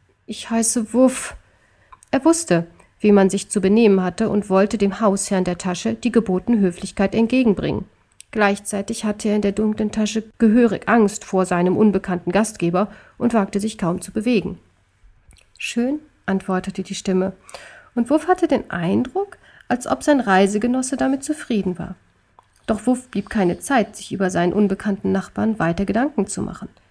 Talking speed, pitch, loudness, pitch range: 155 wpm, 205 Hz, -20 LUFS, 190-230 Hz